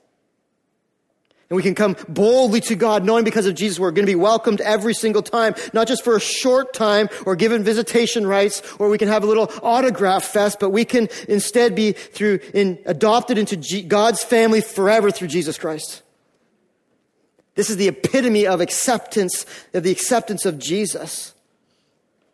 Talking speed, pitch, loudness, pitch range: 170 wpm, 210 Hz, -18 LUFS, 195-230 Hz